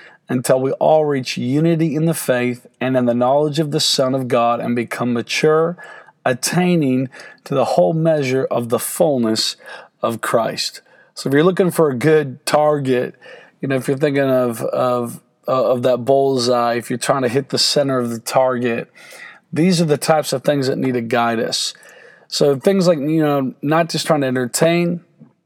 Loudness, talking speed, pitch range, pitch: -17 LUFS, 185 wpm, 125-160 Hz, 140 Hz